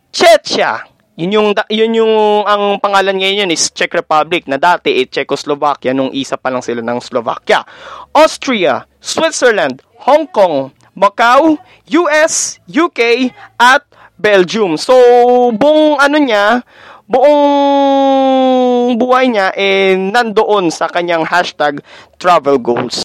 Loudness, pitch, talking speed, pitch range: -11 LUFS, 210 Hz, 120 wpm, 170-270 Hz